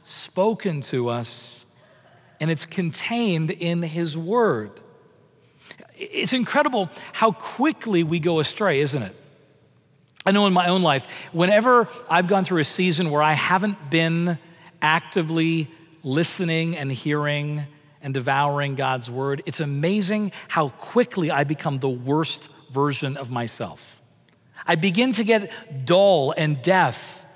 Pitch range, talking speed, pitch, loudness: 145-185 Hz, 130 wpm, 165 Hz, -22 LUFS